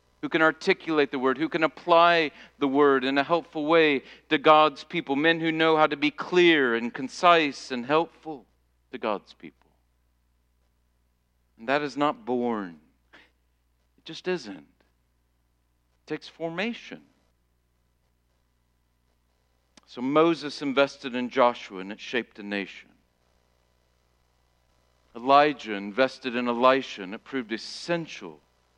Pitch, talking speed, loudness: 120 Hz, 125 wpm, -24 LUFS